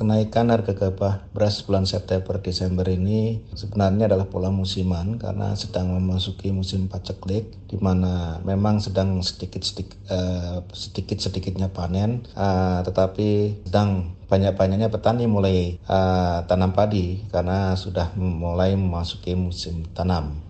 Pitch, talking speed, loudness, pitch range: 95 Hz, 105 wpm, -23 LUFS, 90-100 Hz